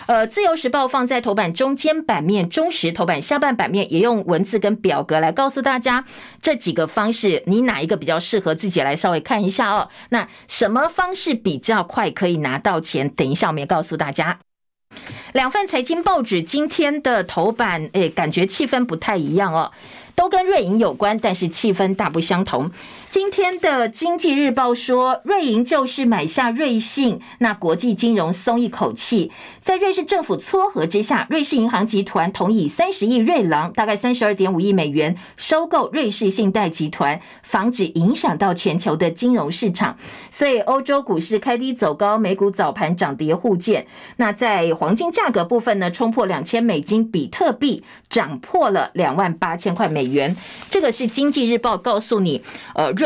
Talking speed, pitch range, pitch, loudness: 280 characters per minute, 180-260 Hz, 220 Hz, -19 LUFS